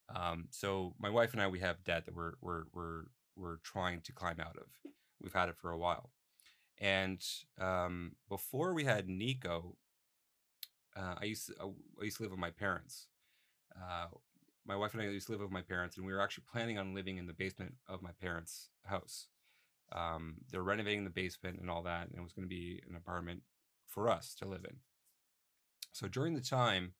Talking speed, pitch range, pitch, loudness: 205 wpm, 85-100 Hz, 90 Hz, -41 LUFS